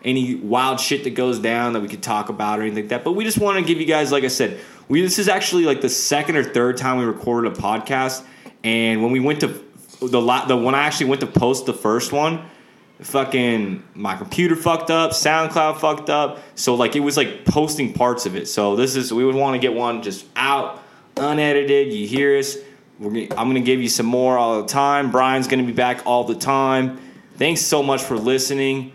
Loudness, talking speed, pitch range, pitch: -19 LUFS, 235 wpm, 120-150 Hz, 130 Hz